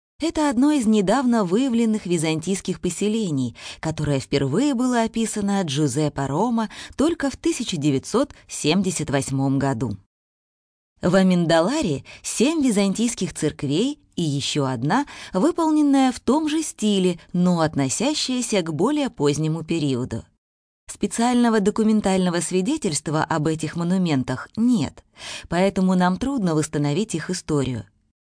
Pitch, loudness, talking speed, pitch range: 185 Hz, -22 LUFS, 105 wpm, 145-235 Hz